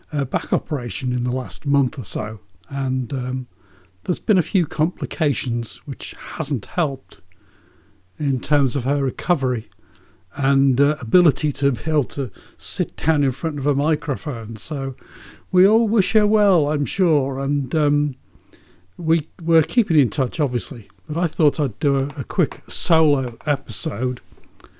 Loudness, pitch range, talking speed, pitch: -21 LUFS, 125-155 Hz, 150 wpm, 140 Hz